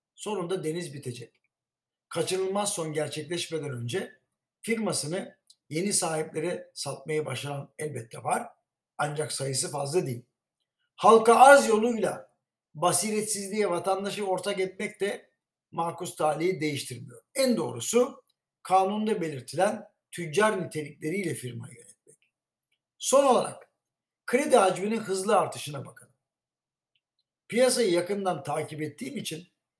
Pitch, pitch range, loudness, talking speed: 180 Hz, 155-210 Hz, -27 LUFS, 100 wpm